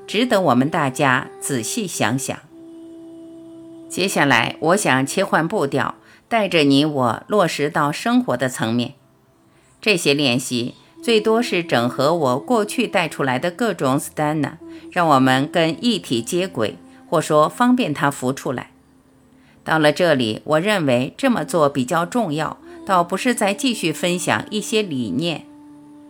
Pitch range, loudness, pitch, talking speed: 135-220 Hz, -19 LUFS, 165 Hz, 220 characters per minute